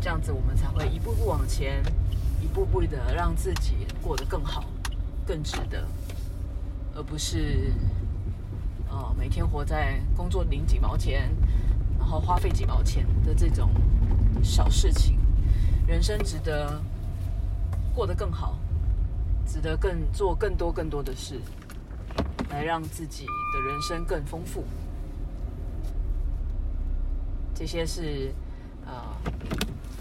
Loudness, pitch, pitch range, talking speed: -29 LUFS, 90 Hz, 80-95 Hz, 170 characters per minute